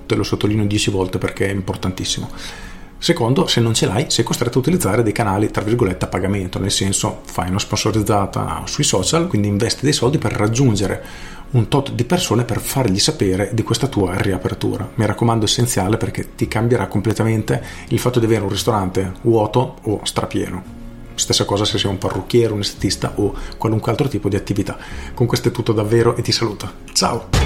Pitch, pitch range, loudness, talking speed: 110 Hz, 100-120 Hz, -18 LUFS, 190 wpm